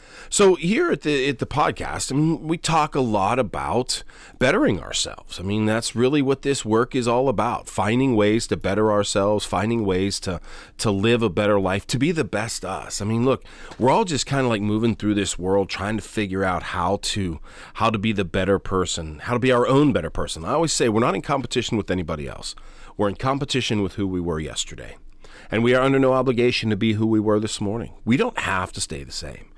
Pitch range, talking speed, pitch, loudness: 95-125 Hz, 230 wpm, 105 Hz, -22 LUFS